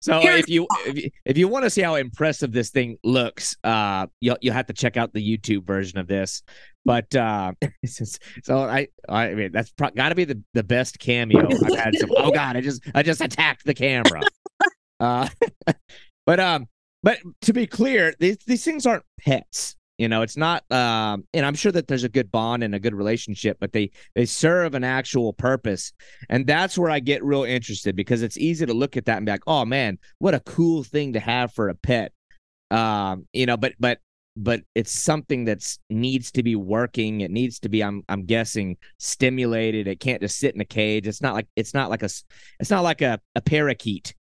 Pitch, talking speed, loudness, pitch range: 125 Hz, 215 wpm, -22 LUFS, 110-145 Hz